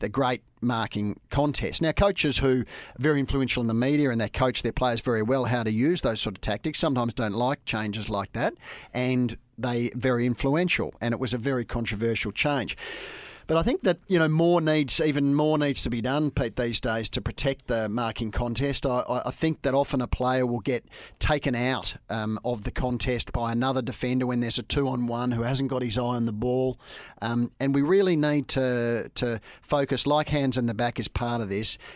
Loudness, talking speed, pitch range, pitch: -26 LUFS, 210 wpm, 115-140 Hz, 125 Hz